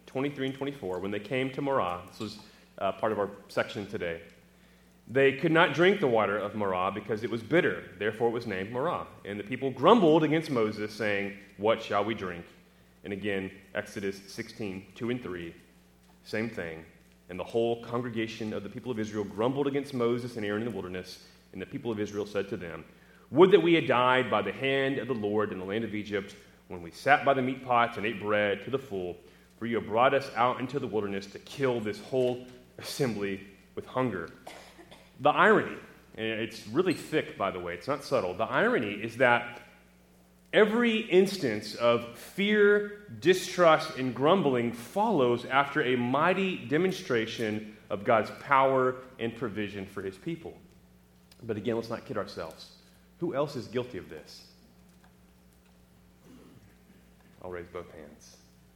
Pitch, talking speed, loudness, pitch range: 110 Hz, 180 wpm, -29 LUFS, 95-130 Hz